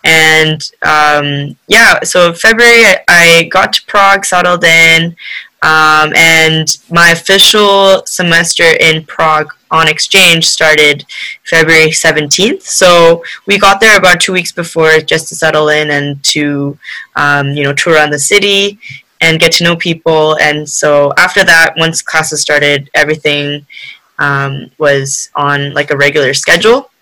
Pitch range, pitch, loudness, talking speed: 150-175 Hz, 160 Hz, -7 LUFS, 140 wpm